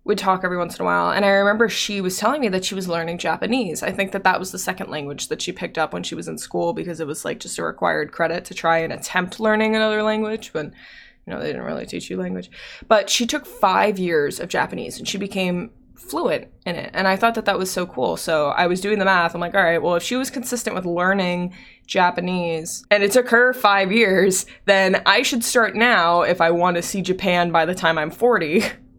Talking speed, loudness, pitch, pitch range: 250 wpm, -20 LUFS, 190 Hz, 170-215 Hz